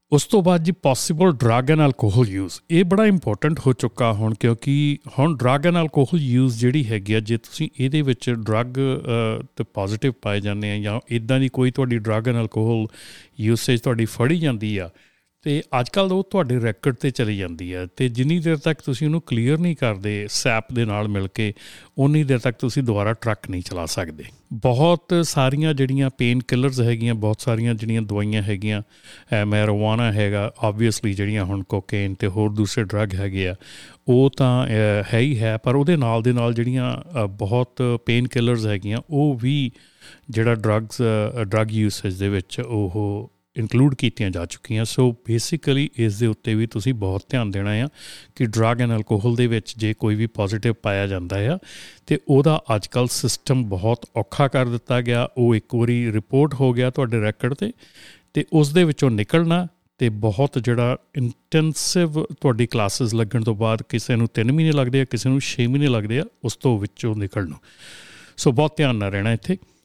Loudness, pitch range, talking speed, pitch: -21 LUFS, 110-135 Hz, 175 wpm, 120 Hz